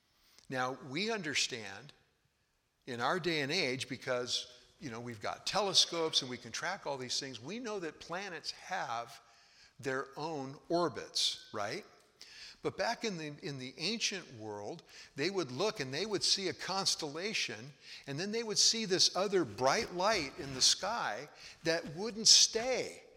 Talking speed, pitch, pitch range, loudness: 160 wpm, 150 Hz, 125-195 Hz, -33 LUFS